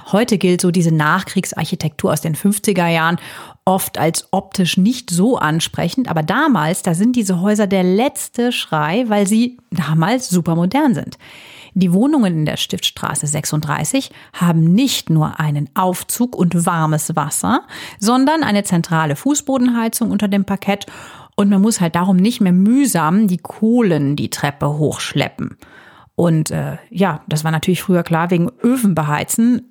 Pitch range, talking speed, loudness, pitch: 160-220 Hz, 150 wpm, -16 LUFS, 185 Hz